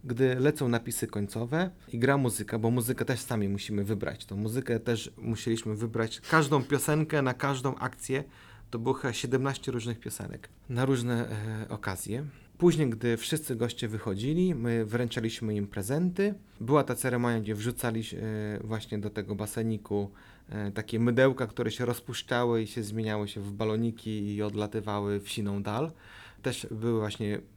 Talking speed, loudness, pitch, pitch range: 150 wpm, -31 LUFS, 115 Hz, 110-130 Hz